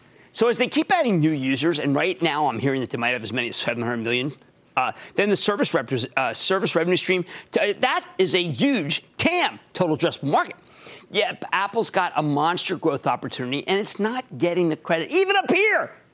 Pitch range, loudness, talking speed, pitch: 140-215 Hz, -22 LUFS, 205 wpm, 175 Hz